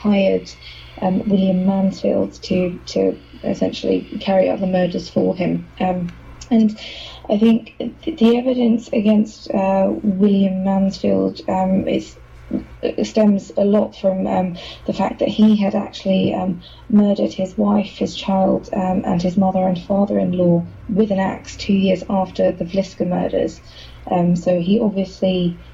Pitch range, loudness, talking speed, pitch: 180-205 Hz, -18 LUFS, 145 wpm, 190 Hz